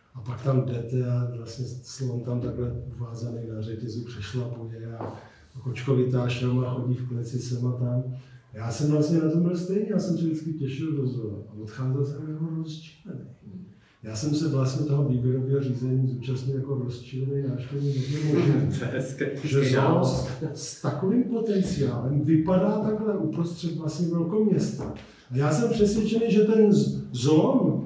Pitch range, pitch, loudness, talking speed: 125-155 Hz, 135 Hz, -26 LUFS, 150 wpm